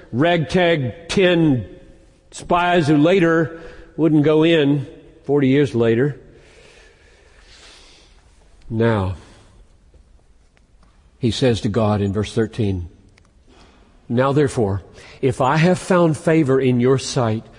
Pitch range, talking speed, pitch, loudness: 100-155 Hz, 100 wpm, 130 Hz, -18 LUFS